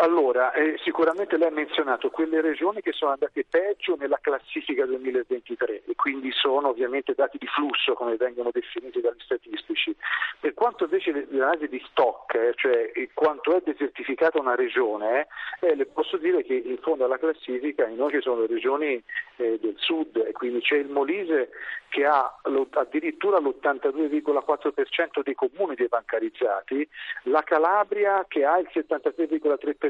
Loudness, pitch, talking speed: -25 LUFS, 325 Hz, 140 wpm